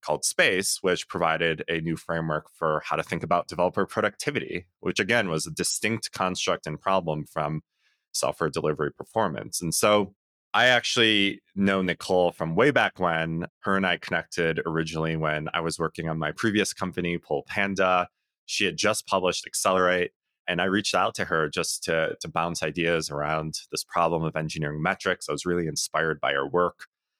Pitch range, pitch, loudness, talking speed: 80-90 Hz, 85 Hz, -26 LUFS, 175 wpm